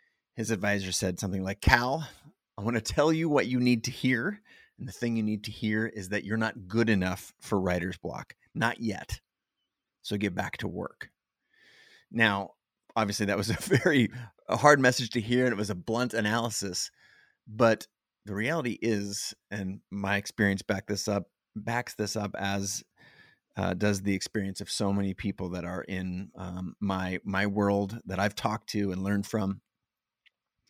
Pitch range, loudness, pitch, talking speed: 100-115 Hz, -29 LUFS, 105 Hz, 180 wpm